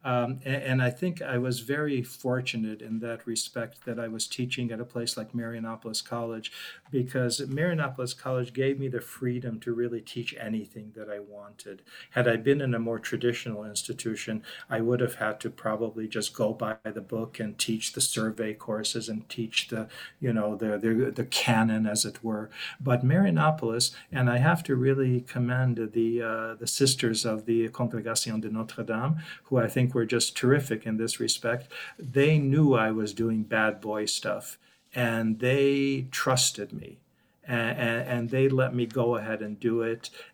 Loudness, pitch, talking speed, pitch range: -28 LUFS, 115 Hz, 175 wpm, 110-130 Hz